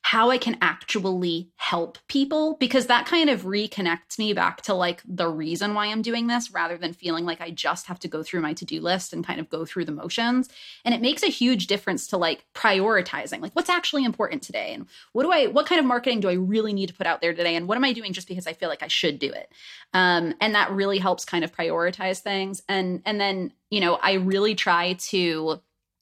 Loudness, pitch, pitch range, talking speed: -24 LUFS, 195 Hz, 175-235 Hz, 240 wpm